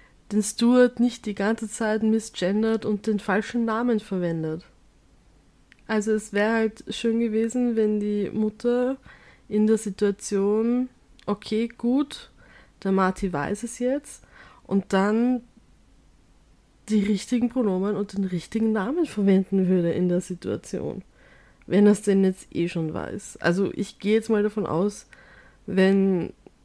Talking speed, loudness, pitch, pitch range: 135 wpm, -24 LUFS, 210 Hz, 195-225 Hz